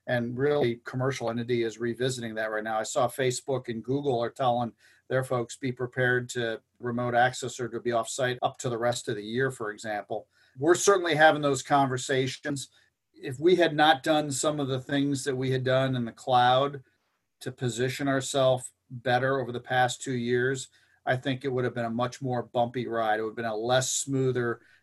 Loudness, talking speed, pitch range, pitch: -28 LUFS, 205 wpm, 120-135 Hz, 125 Hz